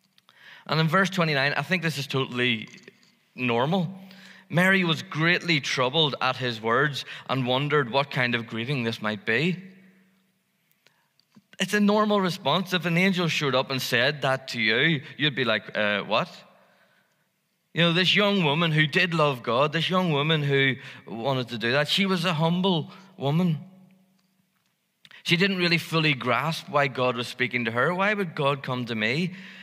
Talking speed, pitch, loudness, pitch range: 170 wpm, 160 Hz, -24 LUFS, 130-185 Hz